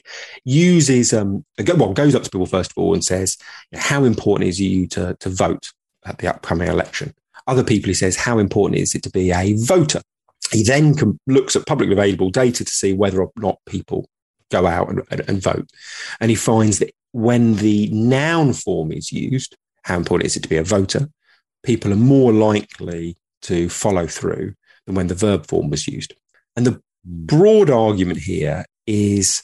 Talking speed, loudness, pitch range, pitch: 190 wpm, -18 LUFS, 95-125 Hz, 105 Hz